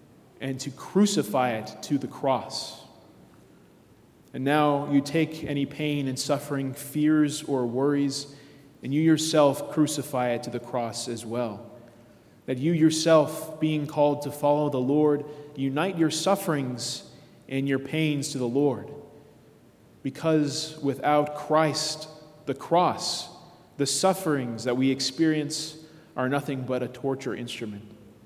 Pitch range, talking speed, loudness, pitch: 130-155 Hz, 130 wpm, -26 LUFS, 145 Hz